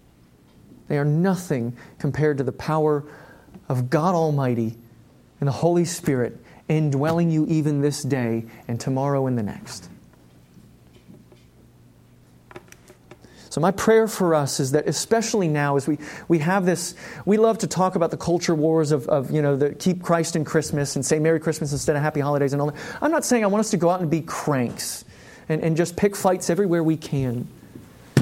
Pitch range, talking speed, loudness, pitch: 135-170 Hz, 185 wpm, -22 LUFS, 150 Hz